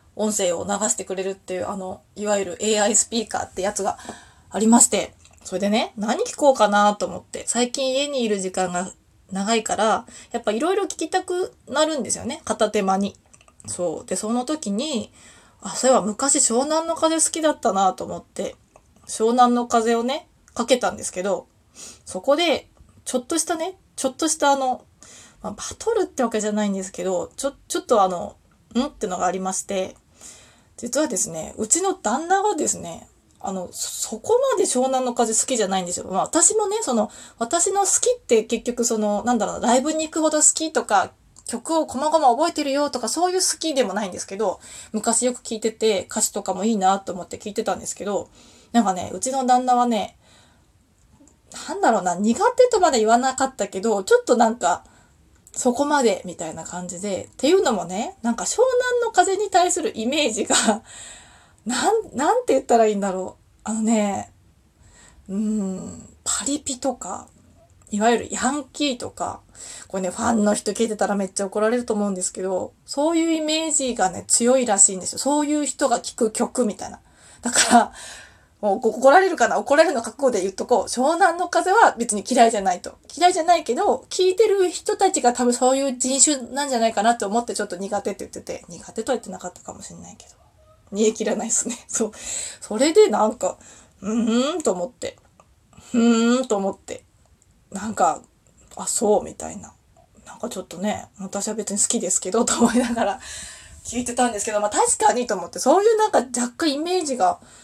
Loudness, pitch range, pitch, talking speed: -21 LUFS, 205-295 Hz, 235 Hz, 375 characters per minute